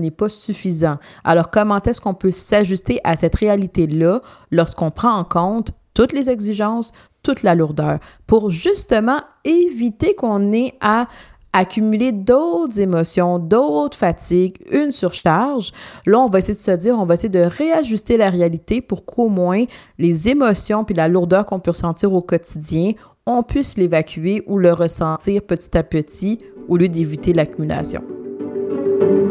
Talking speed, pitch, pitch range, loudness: 155 wpm, 195 Hz, 170-225 Hz, -17 LUFS